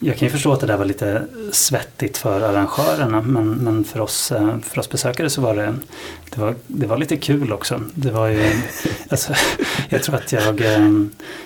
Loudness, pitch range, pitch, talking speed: -19 LUFS, 105-140 Hz, 110 Hz, 195 wpm